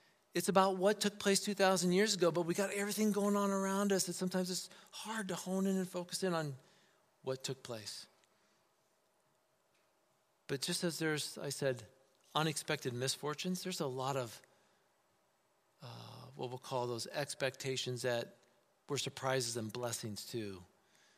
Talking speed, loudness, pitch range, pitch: 155 wpm, -37 LUFS, 130-195 Hz, 170 Hz